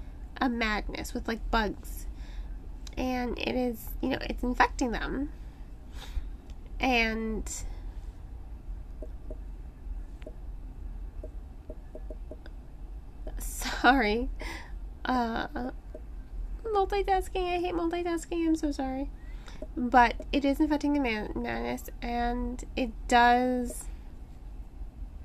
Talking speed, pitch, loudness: 80 wpm, 220 Hz, -29 LUFS